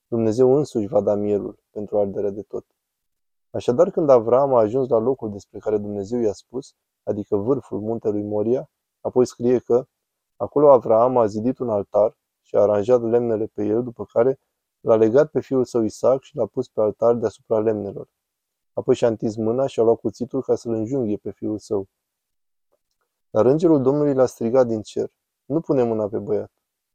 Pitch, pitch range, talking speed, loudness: 115 Hz, 105-130 Hz, 180 wpm, -21 LUFS